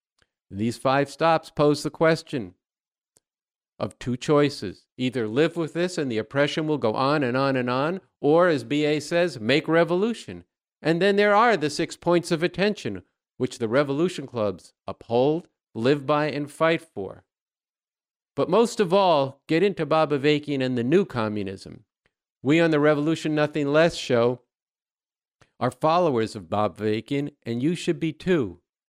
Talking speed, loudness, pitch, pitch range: 160 wpm, -23 LUFS, 150 Hz, 125-165 Hz